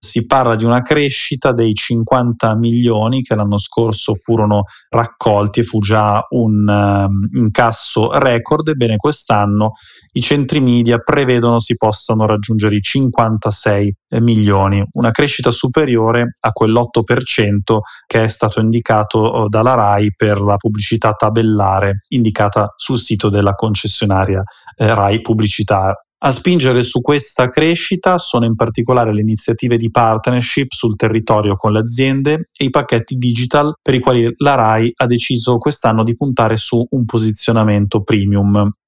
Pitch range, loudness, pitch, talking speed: 105-125 Hz, -14 LUFS, 115 Hz, 140 wpm